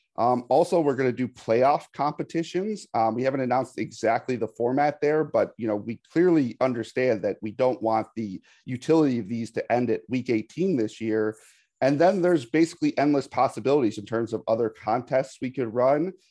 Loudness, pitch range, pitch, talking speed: -25 LUFS, 115-150 Hz, 130 Hz, 190 wpm